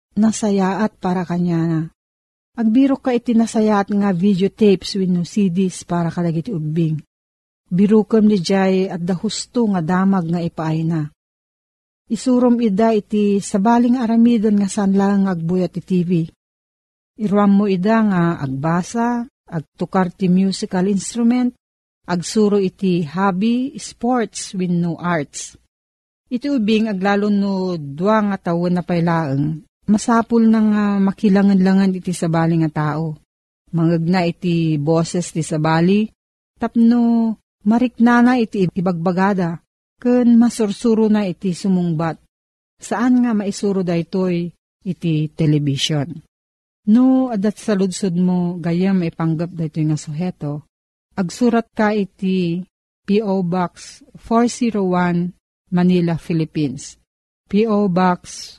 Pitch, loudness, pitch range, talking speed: 190 Hz, -18 LUFS, 170-215 Hz, 120 wpm